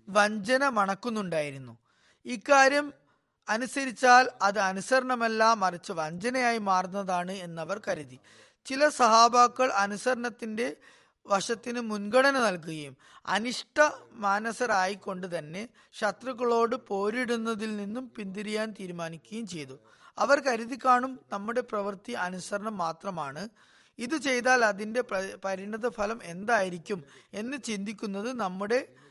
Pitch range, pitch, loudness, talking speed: 195-245 Hz, 215 Hz, -28 LUFS, 90 wpm